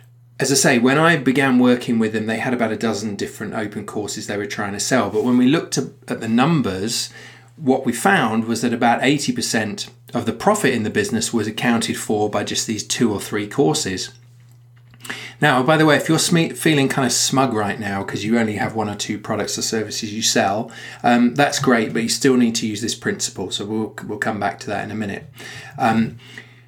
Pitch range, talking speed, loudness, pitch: 110-130 Hz, 225 wpm, -19 LUFS, 120 Hz